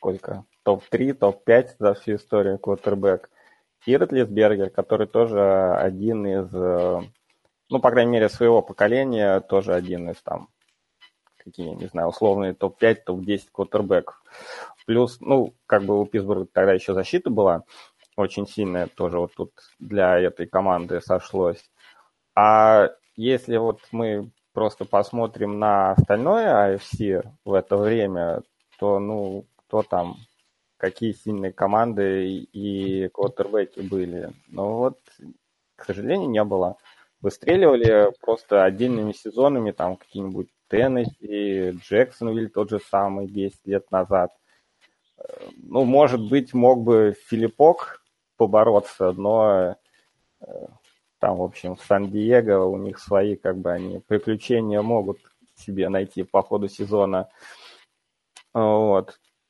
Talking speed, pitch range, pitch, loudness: 120 wpm, 95-115 Hz, 100 Hz, -22 LUFS